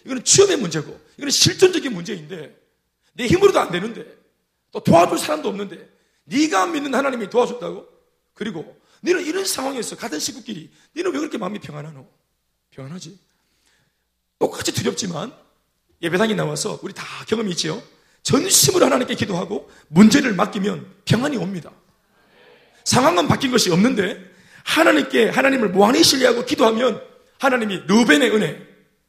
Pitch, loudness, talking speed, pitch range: 225 Hz, -18 LUFS, 345 characters per minute, 180-275 Hz